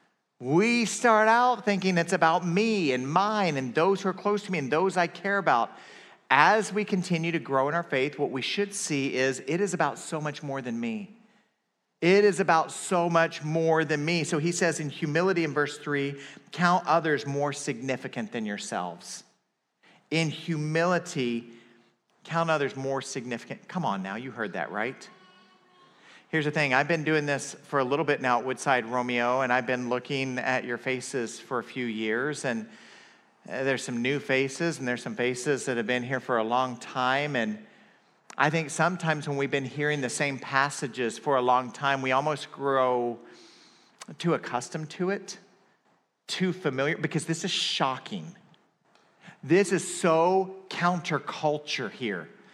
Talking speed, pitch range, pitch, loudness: 175 wpm, 130-180 Hz, 150 Hz, -27 LUFS